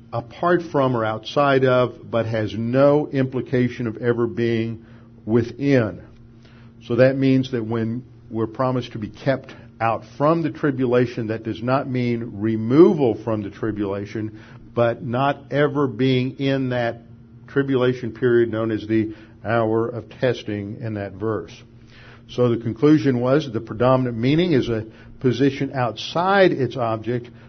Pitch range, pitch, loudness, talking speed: 115-130 Hz, 120 Hz, -21 LUFS, 145 wpm